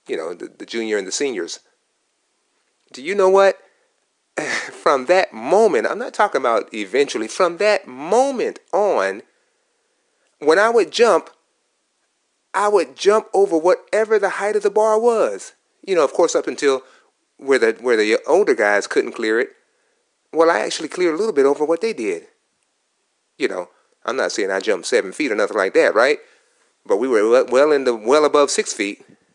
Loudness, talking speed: -18 LUFS, 180 wpm